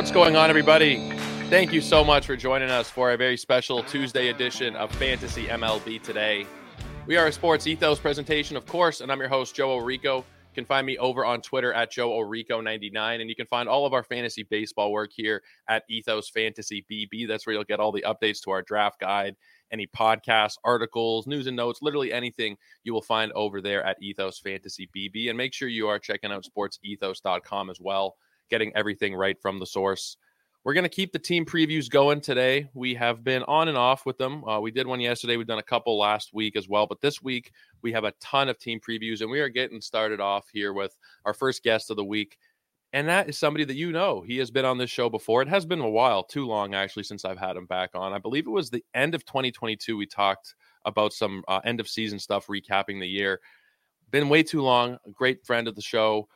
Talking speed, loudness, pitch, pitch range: 230 wpm, -26 LUFS, 115 Hz, 105-130 Hz